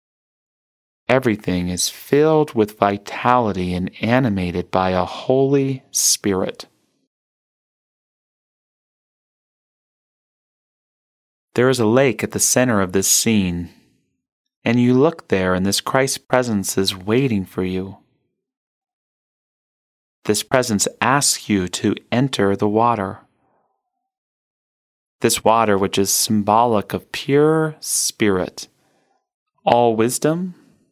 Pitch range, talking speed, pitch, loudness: 95-135 Hz, 100 wpm, 110 Hz, -18 LUFS